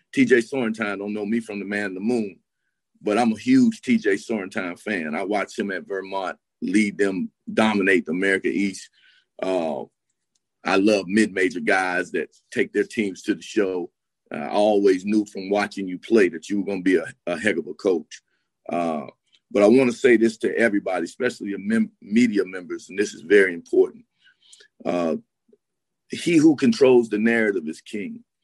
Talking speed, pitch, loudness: 185 wpm, 110 Hz, -22 LUFS